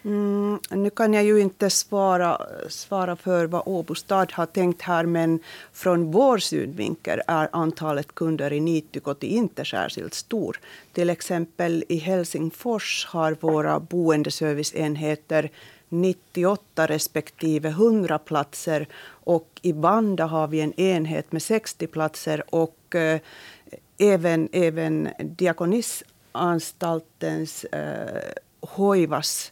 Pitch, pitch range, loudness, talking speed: 170 Hz, 155-185 Hz, -24 LUFS, 110 wpm